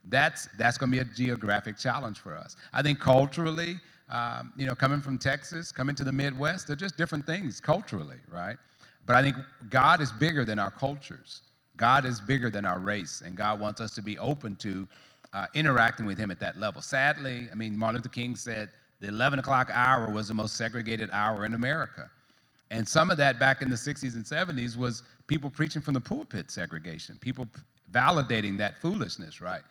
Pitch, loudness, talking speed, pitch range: 125 Hz, -29 LUFS, 200 wpm, 110-140 Hz